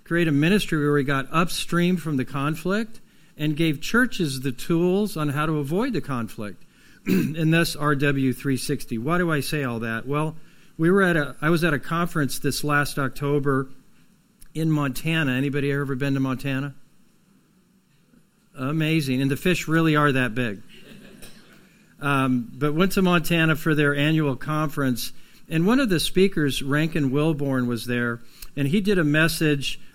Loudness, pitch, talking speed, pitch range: -23 LUFS, 150 Hz, 160 wpm, 140-170 Hz